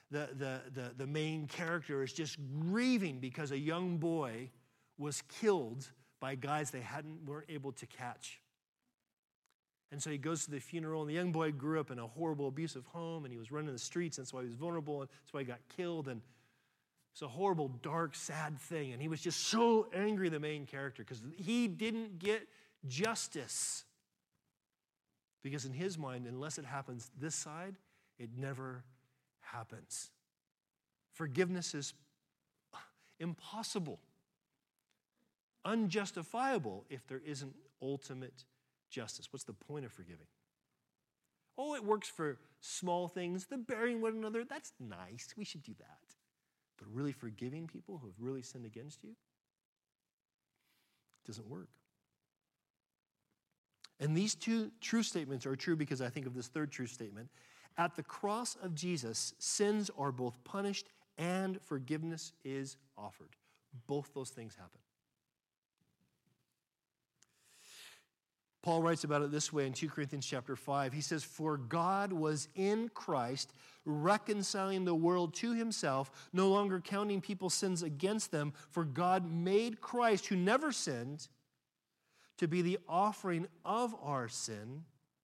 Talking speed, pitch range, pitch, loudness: 150 wpm, 135-185 Hz, 150 Hz, -39 LUFS